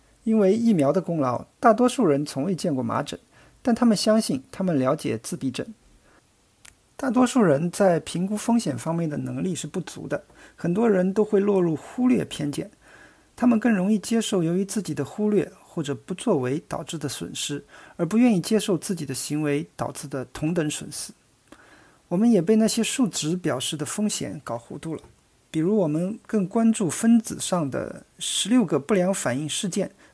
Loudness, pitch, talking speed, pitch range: -24 LUFS, 185 Hz, 275 characters per minute, 150-220 Hz